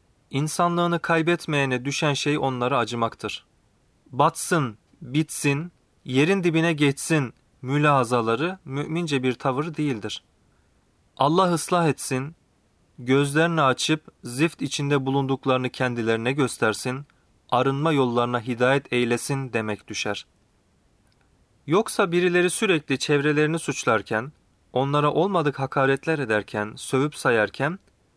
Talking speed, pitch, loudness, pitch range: 90 wpm, 140 Hz, -23 LUFS, 125-160 Hz